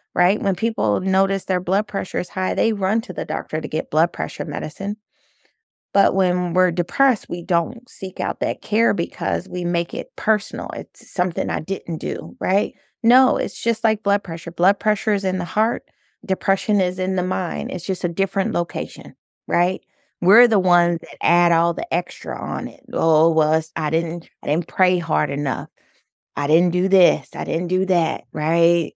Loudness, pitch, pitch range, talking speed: -21 LUFS, 185 Hz, 170-205 Hz, 190 wpm